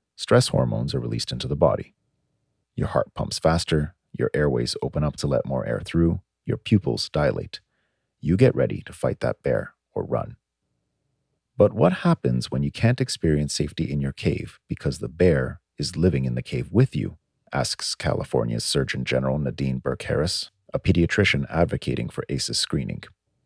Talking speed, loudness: 170 wpm, -24 LUFS